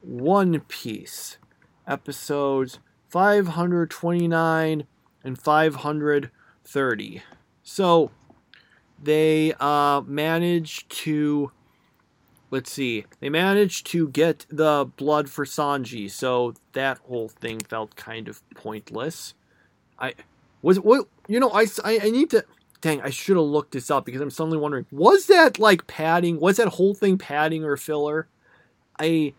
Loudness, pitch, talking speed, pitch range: -22 LUFS, 155 Hz, 125 wpm, 140-170 Hz